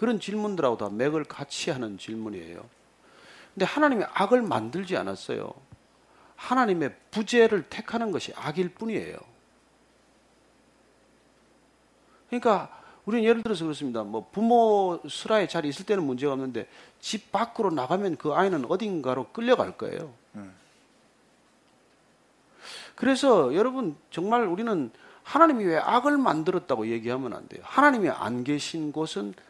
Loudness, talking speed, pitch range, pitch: -26 LUFS, 300 characters per minute, 140-230 Hz, 185 Hz